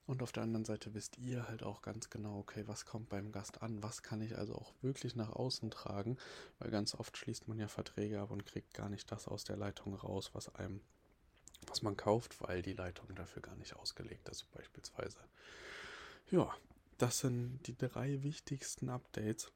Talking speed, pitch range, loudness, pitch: 195 wpm, 100-125 Hz, -43 LUFS, 110 Hz